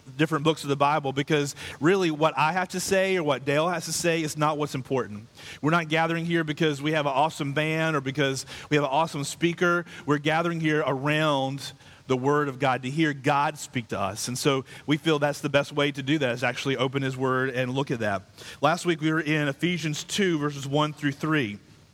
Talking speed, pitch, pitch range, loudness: 230 wpm, 150 Hz, 140-160 Hz, -26 LUFS